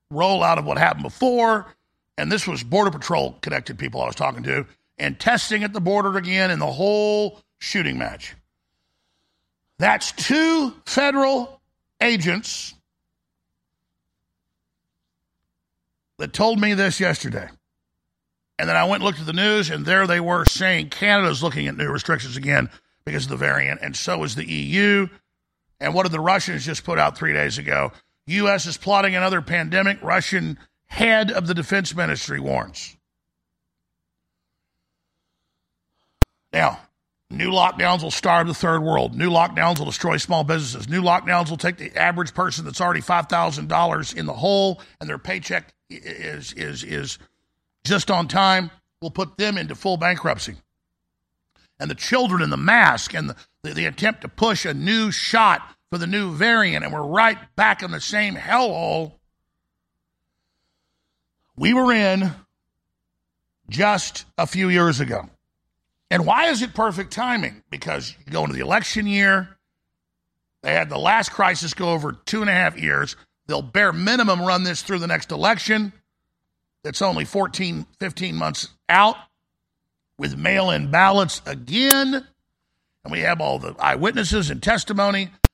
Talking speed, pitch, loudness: 155 wpm, 175 Hz, -20 LUFS